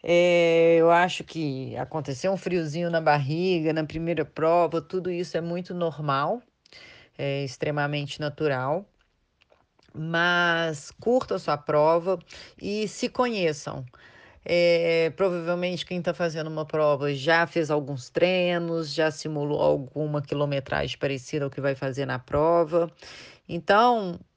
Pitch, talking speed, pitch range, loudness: 165 Hz, 125 wpm, 150-175 Hz, -25 LUFS